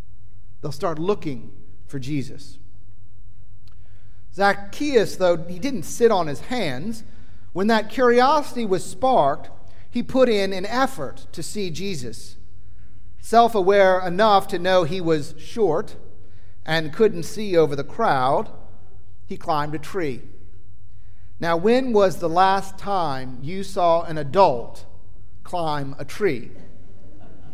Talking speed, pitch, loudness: 125 wpm, 150 Hz, -21 LUFS